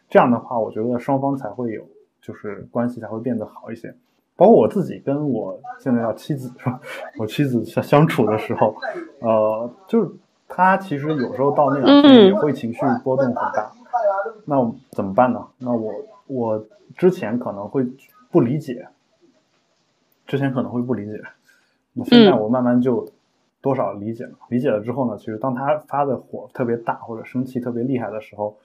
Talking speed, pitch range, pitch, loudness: 270 characters per minute, 115-145 Hz, 130 Hz, -20 LUFS